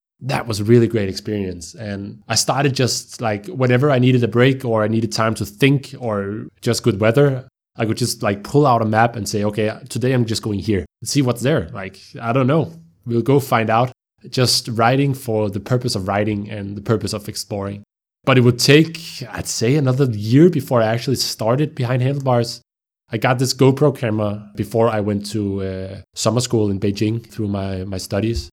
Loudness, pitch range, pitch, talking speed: -18 LUFS, 105-130 Hz, 115 Hz, 205 wpm